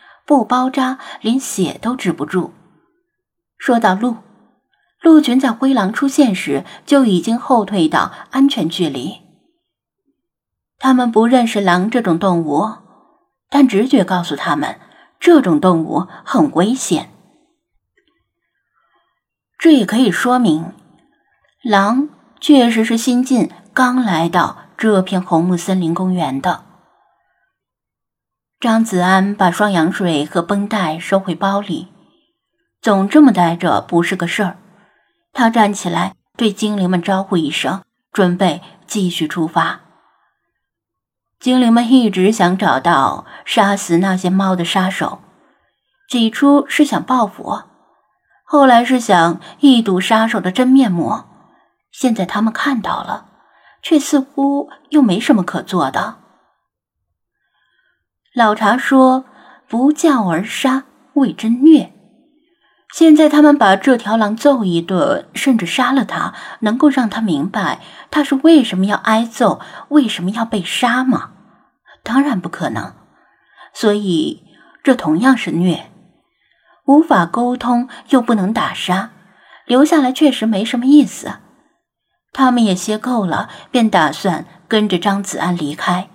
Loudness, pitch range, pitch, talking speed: -14 LUFS, 185-270 Hz, 225 Hz, 185 characters per minute